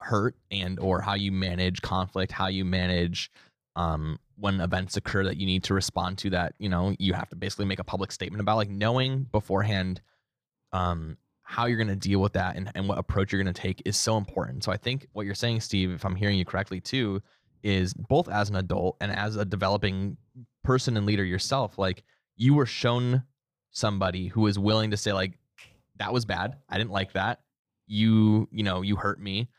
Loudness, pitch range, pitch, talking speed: -28 LUFS, 95-110 Hz, 100 Hz, 205 wpm